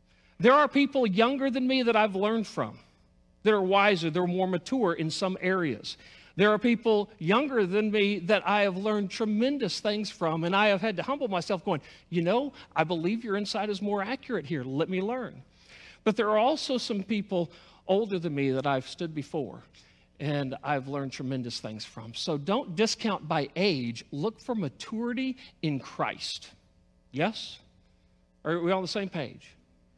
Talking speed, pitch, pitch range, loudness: 180 wpm, 195 Hz, 155-220 Hz, -28 LUFS